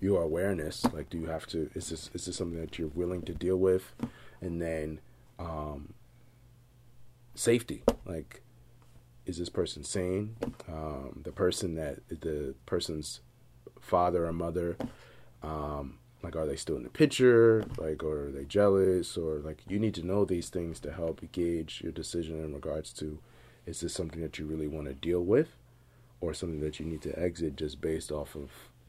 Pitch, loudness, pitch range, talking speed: 85 Hz, -32 LUFS, 80-100 Hz, 180 wpm